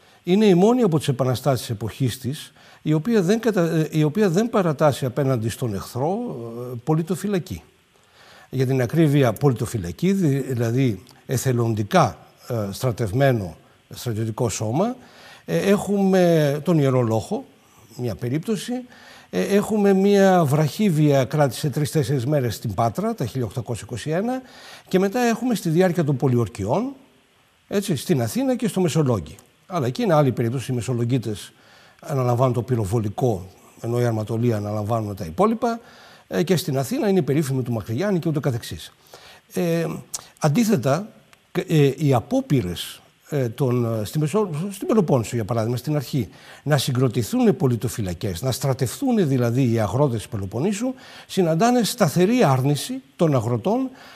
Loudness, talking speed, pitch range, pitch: -22 LUFS, 135 wpm, 120-185 Hz, 140 Hz